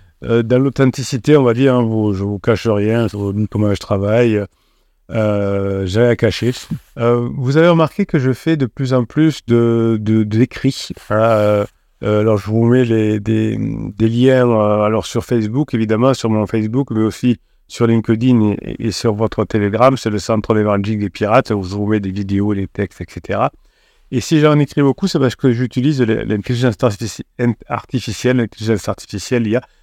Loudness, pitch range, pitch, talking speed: -16 LUFS, 105-125 Hz, 115 Hz, 195 wpm